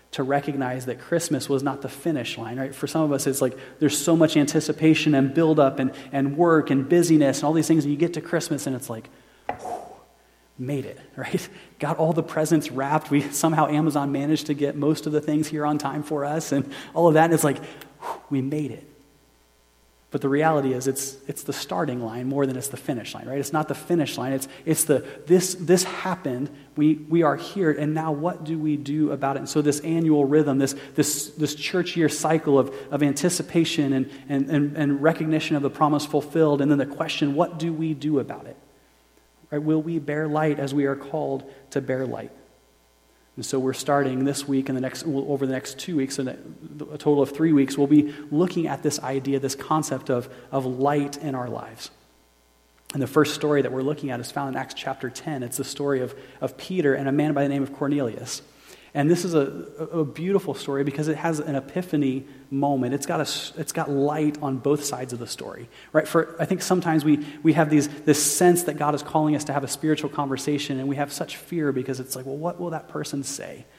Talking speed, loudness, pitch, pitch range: 230 wpm, -24 LUFS, 145 Hz, 135-155 Hz